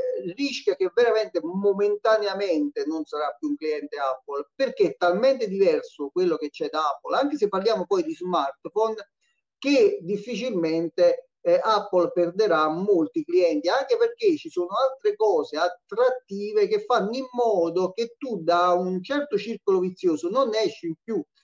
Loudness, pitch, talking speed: -24 LUFS, 220 Hz, 150 wpm